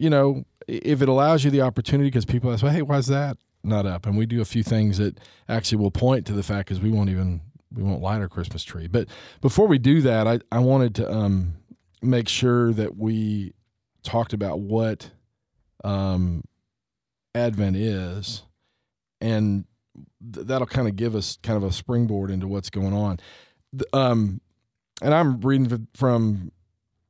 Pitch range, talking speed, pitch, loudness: 100-125 Hz, 180 wpm, 110 Hz, -23 LUFS